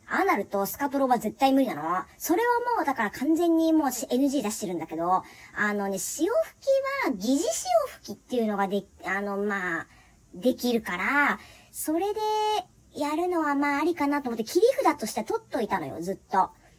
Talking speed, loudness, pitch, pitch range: 350 characters per minute, -27 LUFS, 275 Hz, 210-325 Hz